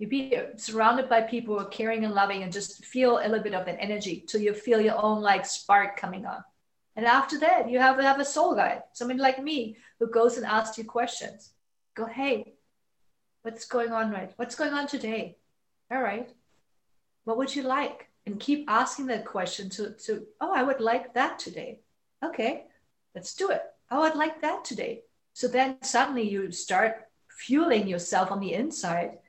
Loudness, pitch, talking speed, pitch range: -27 LUFS, 230 Hz, 195 wpm, 210-265 Hz